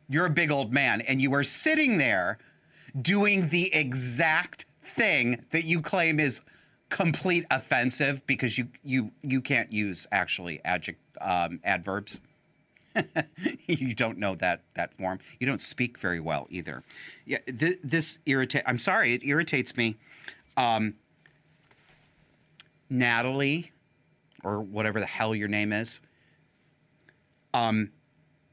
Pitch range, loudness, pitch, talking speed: 120-155 Hz, -27 LUFS, 140 Hz, 130 wpm